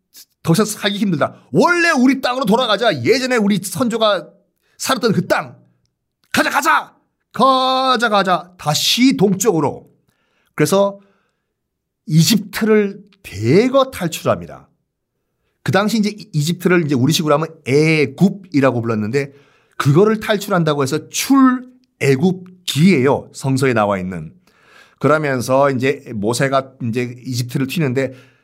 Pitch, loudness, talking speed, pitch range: 170 Hz, -16 LUFS, 270 characters per minute, 135-210 Hz